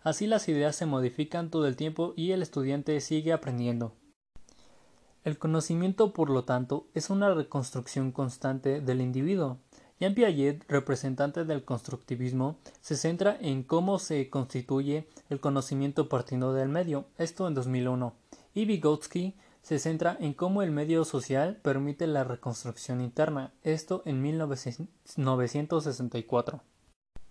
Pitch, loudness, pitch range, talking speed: 145 Hz, -31 LUFS, 135-165 Hz, 130 wpm